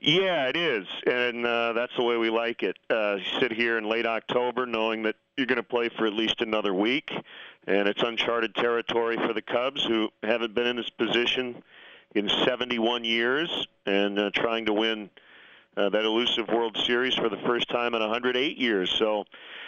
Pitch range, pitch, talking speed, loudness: 110-120 Hz, 115 Hz, 200 wpm, -26 LUFS